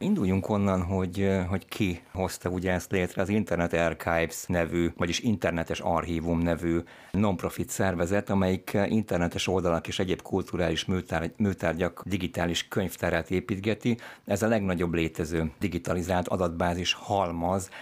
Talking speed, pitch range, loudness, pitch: 120 wpm, 85-100 Hz, -28 LUFS, 90 Hz